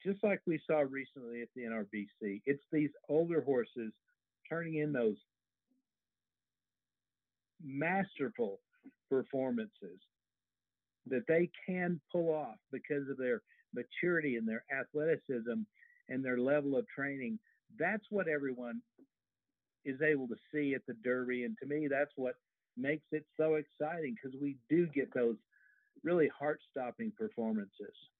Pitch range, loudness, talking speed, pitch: 125-170 Hz, -37 LUFS, 130 wpm, 140 Hz